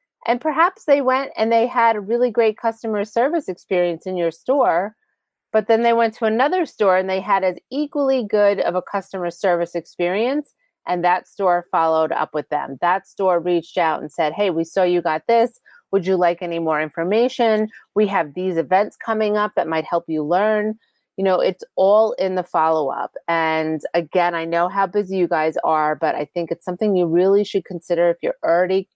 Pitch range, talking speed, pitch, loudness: 170-225 Hz, 205 wpm, 190 Hz, -20 LUFS